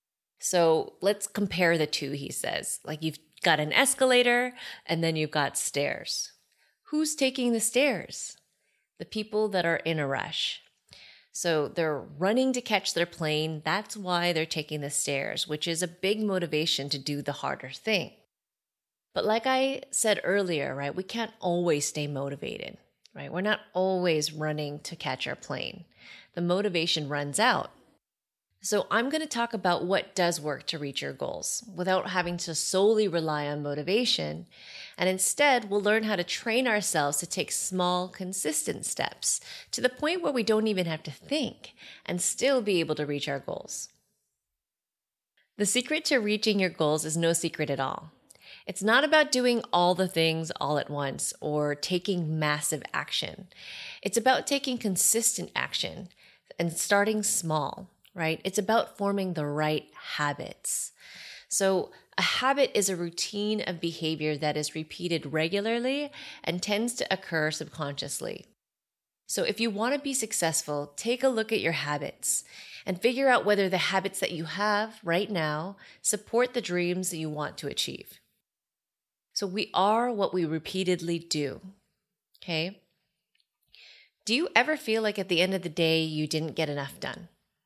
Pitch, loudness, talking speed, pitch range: 180 Hz, -28 LUFS, 165 wpm, 155-215 Hz